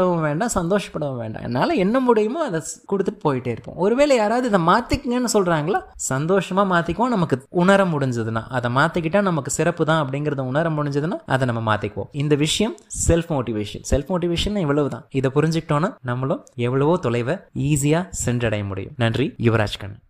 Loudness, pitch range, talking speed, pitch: -21 LUFS, 130-190 Hz, 150 wpm, 150 Hz